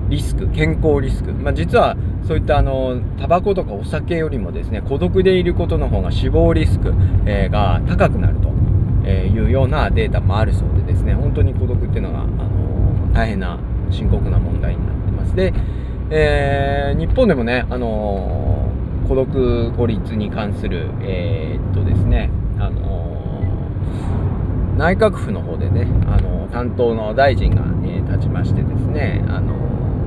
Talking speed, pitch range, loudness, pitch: 300 characters per minute, 95-110 Hz, -18 LUFS, 100 Hz